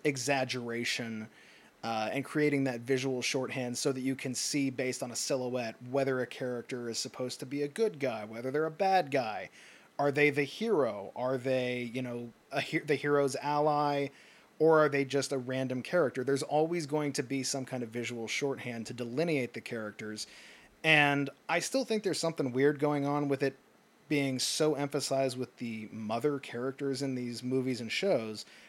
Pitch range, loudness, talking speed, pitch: 125-145 Hz, -32 LUFS, 185 wpm, 135 Hz